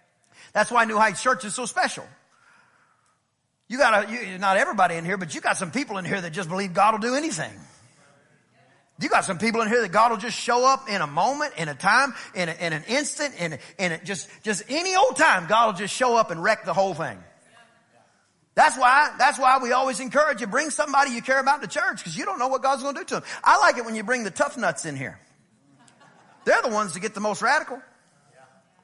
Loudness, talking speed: -23 LUFS, 245 wpm